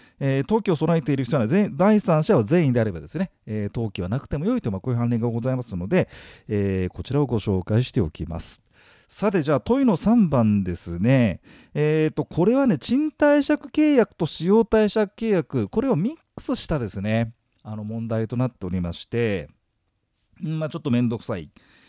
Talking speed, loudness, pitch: 370 characters per minute, -23 LUFS, 130 Hz